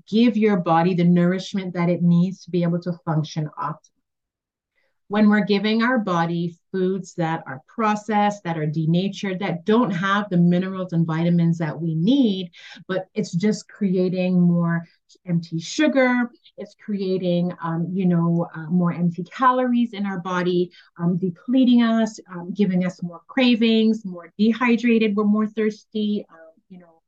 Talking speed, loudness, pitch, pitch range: 155 wpm, -21 LUFS, 185 Hz, 170-215 Hz